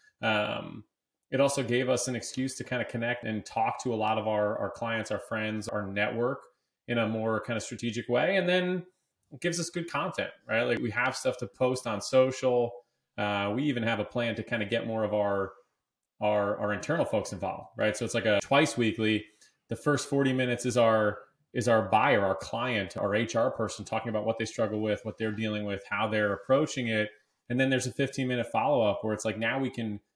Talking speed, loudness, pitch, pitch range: 225 wpm, -29 LUFS, 115 Hz, 110-130 Hz